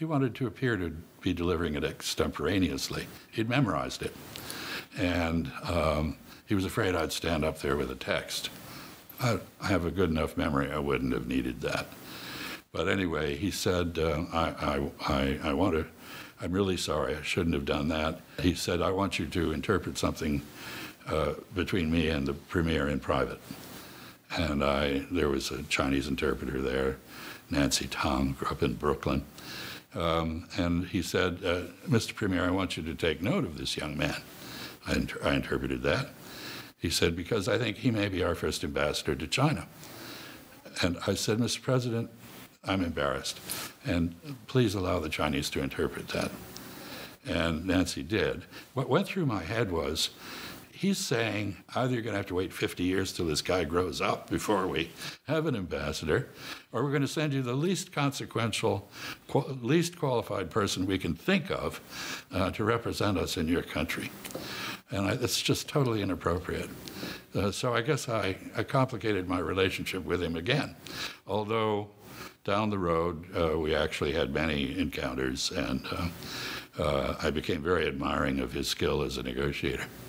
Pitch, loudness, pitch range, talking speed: 90 Hz, -31 LUFS, 75-110 Hz, 170 wpm